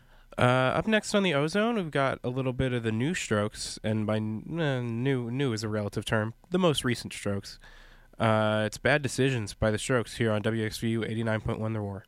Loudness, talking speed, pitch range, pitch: -28 LUFS, 205 wpm, 110-135 Hz, 115 Hz